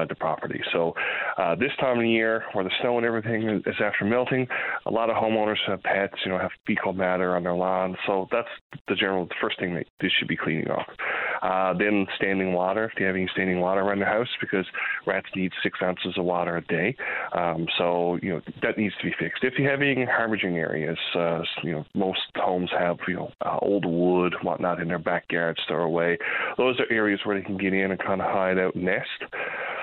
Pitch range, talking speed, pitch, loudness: 90-105 Hz, 225 wpm, 95 Hz, -25 LUFS